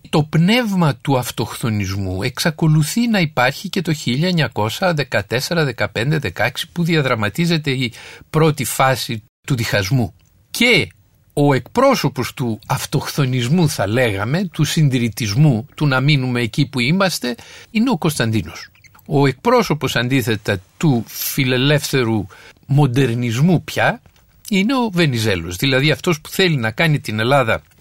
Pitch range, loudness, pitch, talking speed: 115-160 Hz, -17 LUFS, 135 Hz, 115 wpm